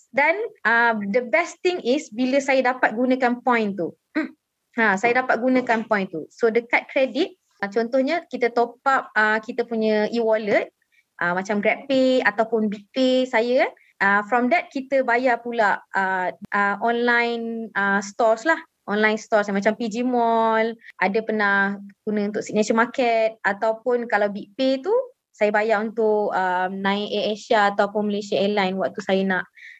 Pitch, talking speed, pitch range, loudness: 230 Hz, 155 wpm, 205-255 Hz, -22 LUFS